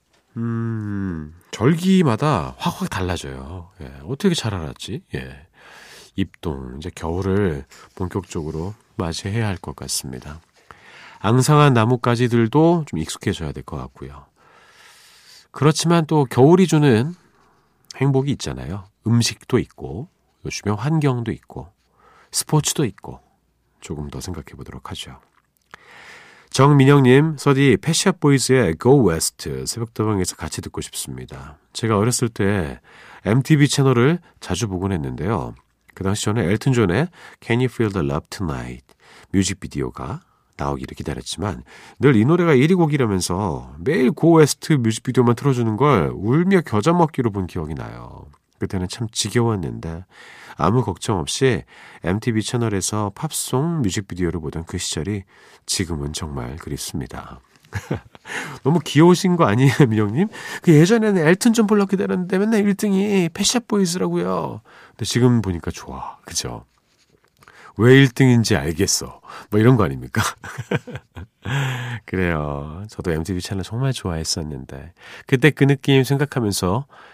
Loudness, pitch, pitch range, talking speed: -19 LUFS, 115 Hz, 90-145 Hz, 305 characters per minute